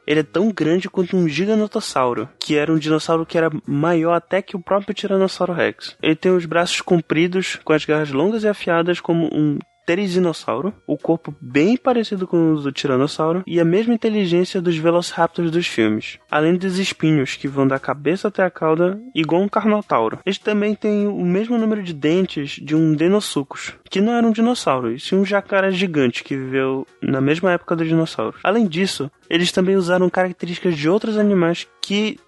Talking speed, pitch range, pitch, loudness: 190 wpm, 155-195 Hz, 175 Hz, -19 LUFS